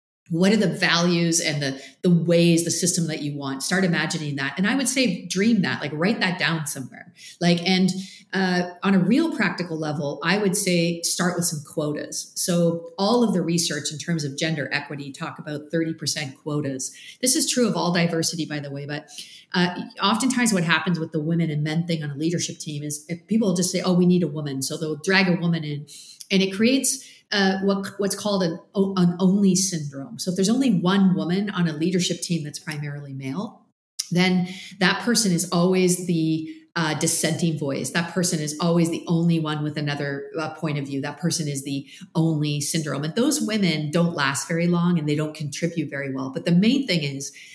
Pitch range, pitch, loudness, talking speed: 155-185 Hz, 170 Hz, -23 LUFS, 210 wpm